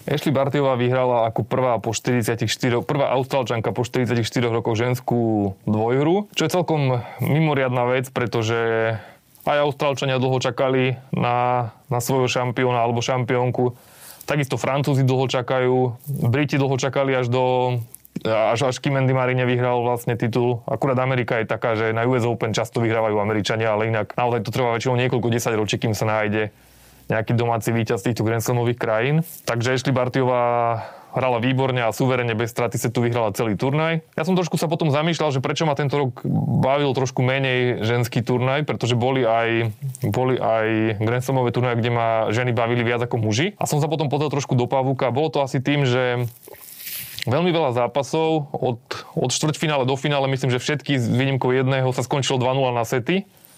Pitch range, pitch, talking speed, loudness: 120-135 Hz, 125 Hz, 170 wpm, -21 LUFS